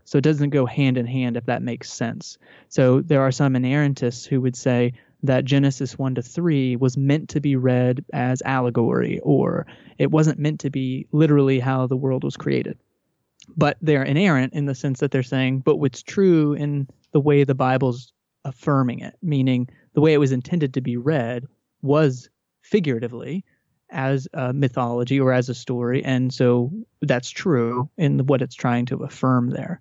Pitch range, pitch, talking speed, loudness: 125-145 Hz, 135 Hz, 185 wpm, -21 LUFS